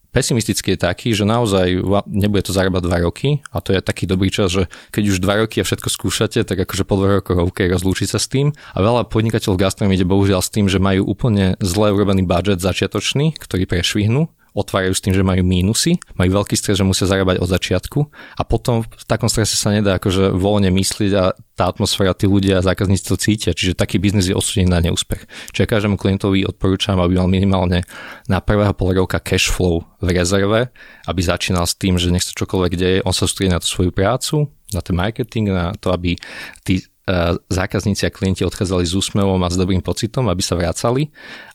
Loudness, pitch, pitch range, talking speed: -17 LUFS, 95 Hz, 95-105 Hz, 205 wpm